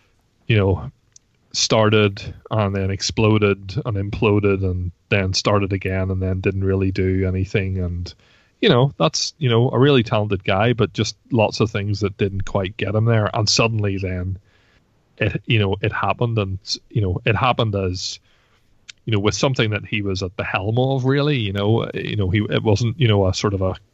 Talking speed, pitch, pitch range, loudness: 195 wpm, 105 Hz, 95-115 Hz, -20 LUFS